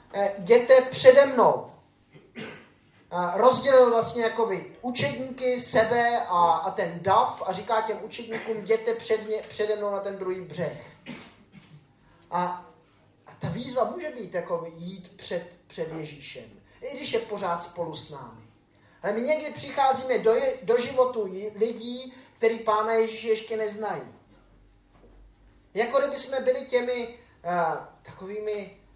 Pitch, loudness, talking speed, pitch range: 220 Hz, -25 LUFS, 130 wpm, 180-245 Hz